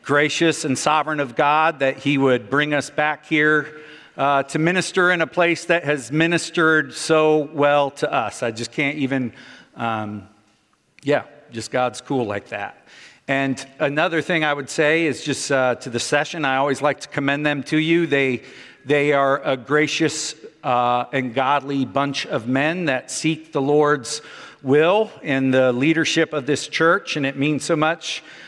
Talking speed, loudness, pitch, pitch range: 175 wpm, -20 LUFS, 145 Hz, 135-155 Hz